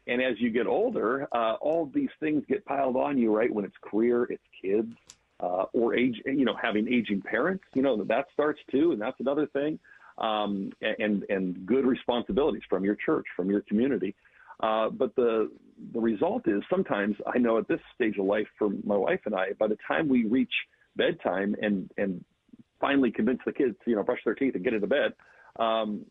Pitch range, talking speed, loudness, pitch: 105-145 Hz, 200 wpm, -28 LUFS, 120 Hz